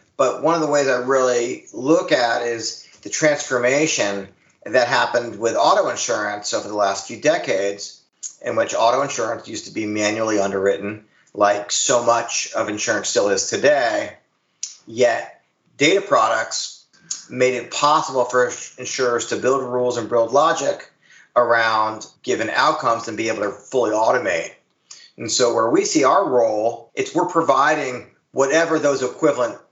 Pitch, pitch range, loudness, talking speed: 125 Hz, 110-145 Hz, -19 LUFS, 150 wpm